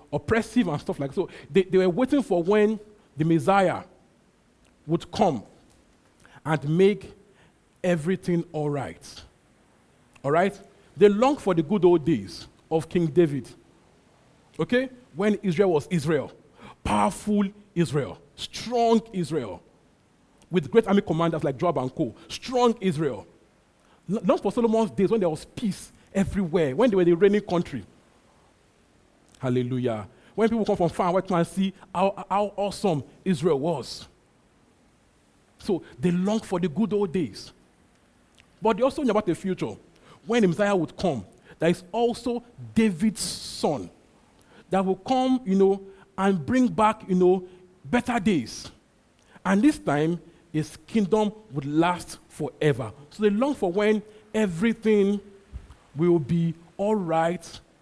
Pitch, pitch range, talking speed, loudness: 185 Hz, 165-210 Hz, 140 wpm, -25 LUFS